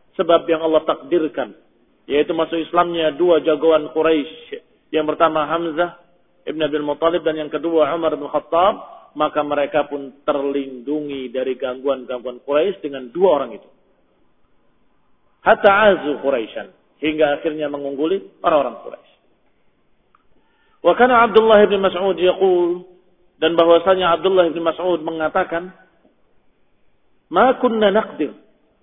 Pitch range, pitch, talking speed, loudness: 150-180 Hz, 165 Hz, 115 wpm, -18 LUFS